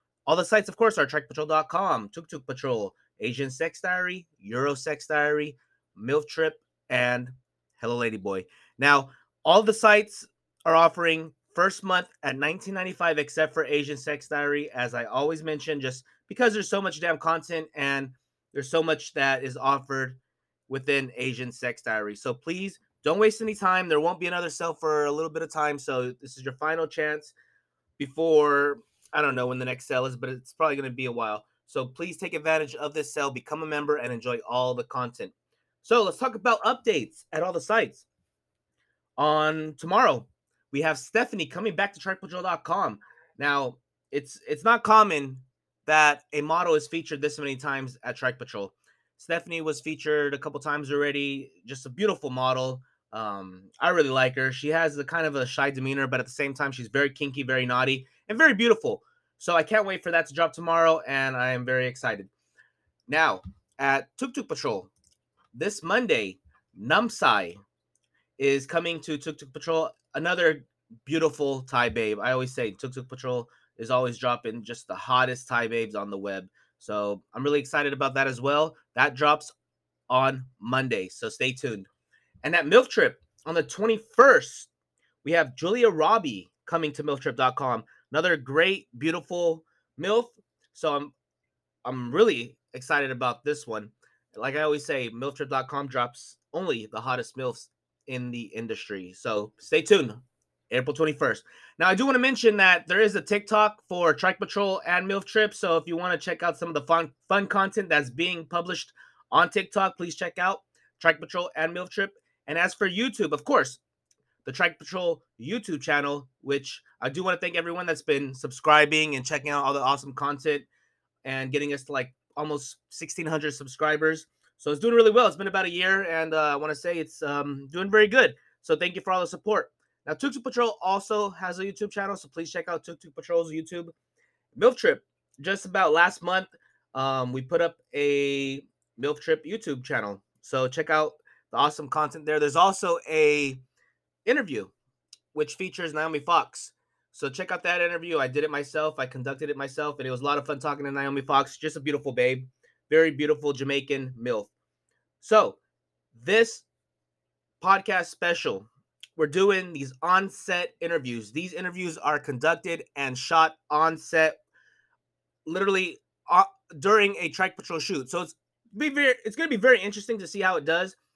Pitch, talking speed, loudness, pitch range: 150 Hz, 180 wpm, -26 LUFS, 135-175 Hz